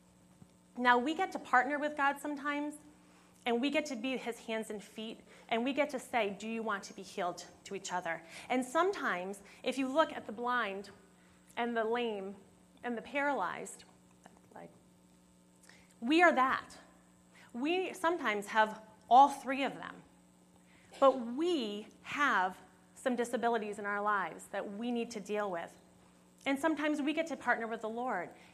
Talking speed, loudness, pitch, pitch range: 165 wpm, -34 LUFS, 230 Hz, 195-270 Hz